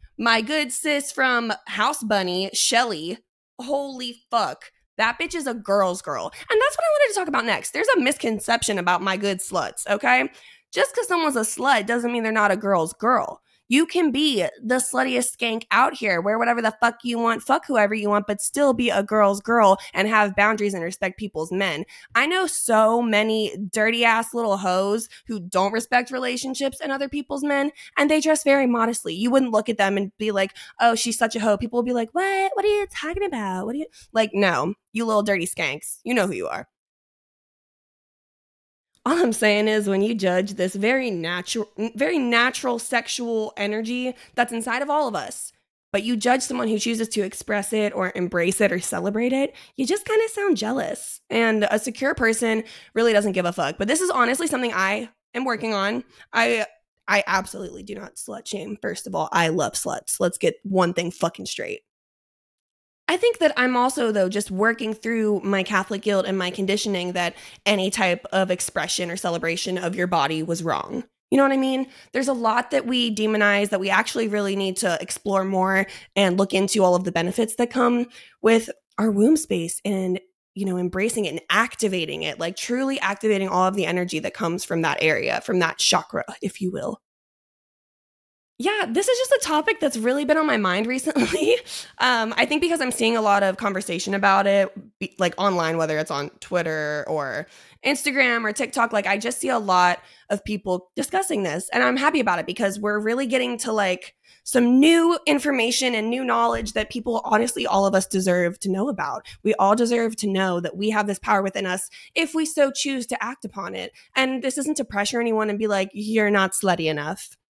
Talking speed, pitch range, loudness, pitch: 205 wpm, 195-255 Hz, -22 LUFS, 220 Hz